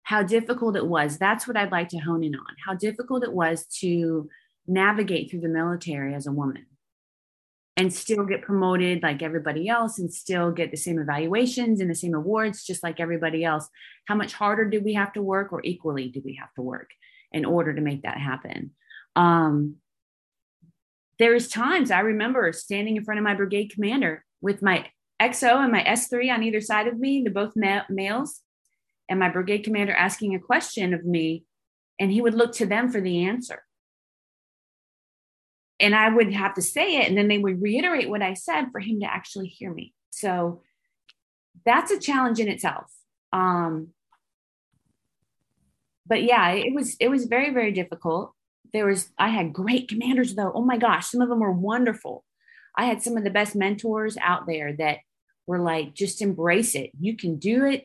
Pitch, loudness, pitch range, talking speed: 200 Hz, -24 LUFS, 170-225 Hz, 190 wpm